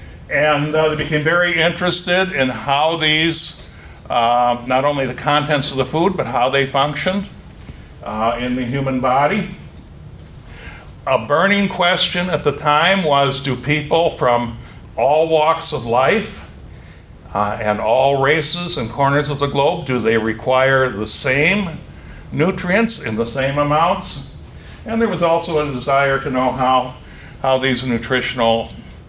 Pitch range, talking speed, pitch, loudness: 120-160 Hz, 145 wpm, 140 Hz, -16 LUFS